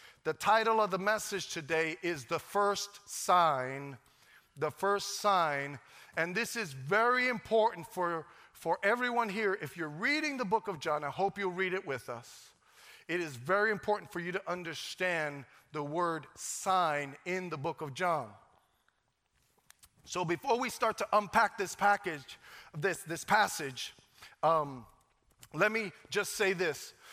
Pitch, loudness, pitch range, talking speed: 180 Hz, -32 LUFS, 155-205 Hz, 155 wpm